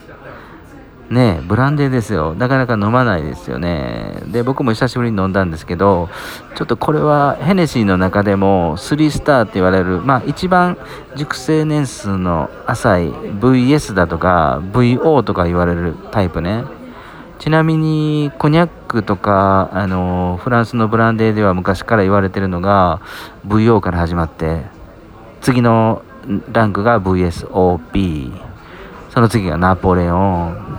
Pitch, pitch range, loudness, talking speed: 105 Hz, 90-130 Hz, -15 LUFS, 310 characters per minute